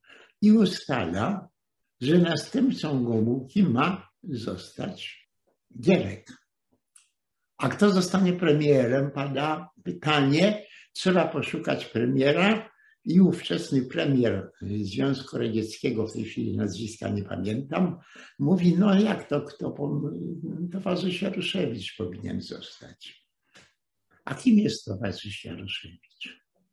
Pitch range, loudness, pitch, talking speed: 115-185 Hz, -26 LUFS, 145 Hz, 95 wpm